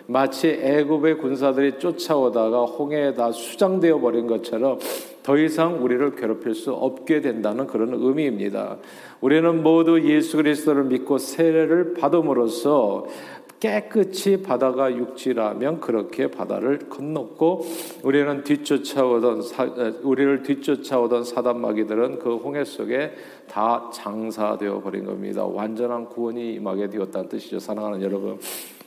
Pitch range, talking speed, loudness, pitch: 120-155 Hz, 310 characters per minute, -22 LUFS, 135 Hz